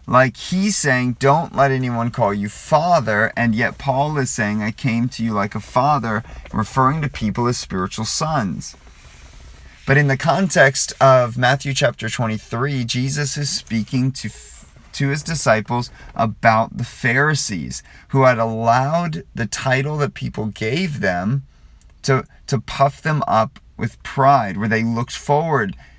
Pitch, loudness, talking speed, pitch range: 125 Hz, -19 LUFS, 150 wpm, 110-140 Hz